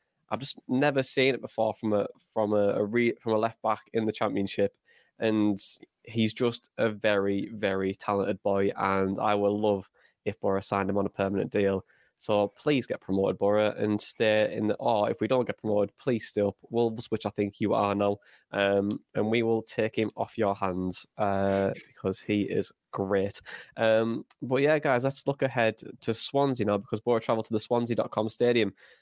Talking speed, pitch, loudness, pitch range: 200 wpm, 105 Hz, -28 LUFS, 100-115 Hz